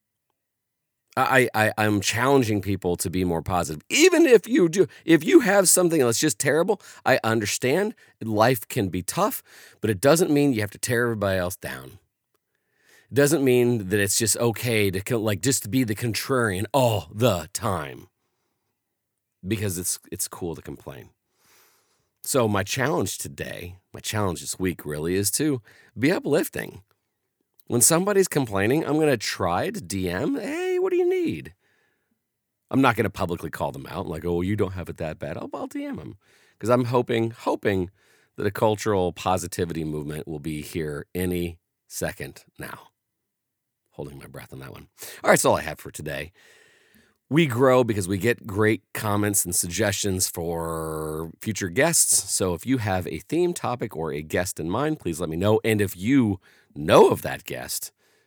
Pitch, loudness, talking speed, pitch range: 110 Hz, -23 LUFS, 175 wpm, 90-130 Hz